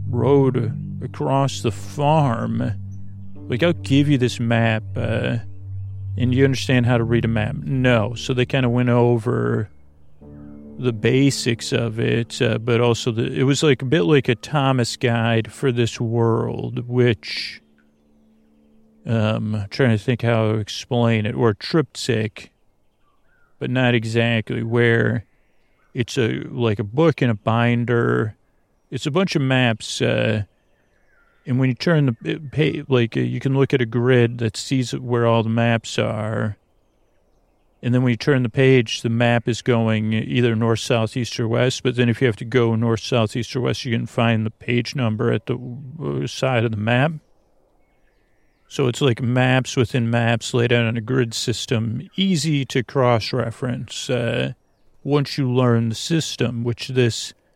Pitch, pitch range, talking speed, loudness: 120 Hz, 110-130 Hz, 170 wpm, -20 LUFS